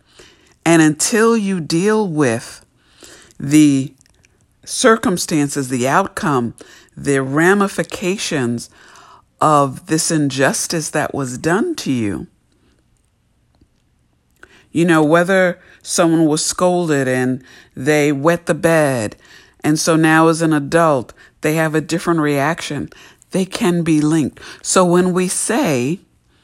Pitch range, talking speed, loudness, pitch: 140-175 Hz, 110 wpm, -16 LUFS, 160 Hz